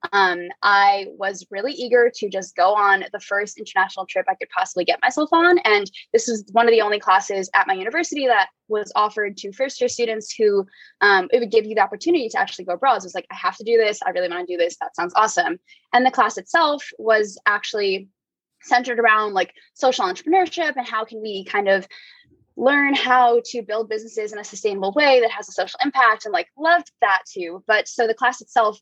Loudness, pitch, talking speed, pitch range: -20 LUFS, 220 Hz, 225 wpm, 195-255 Hz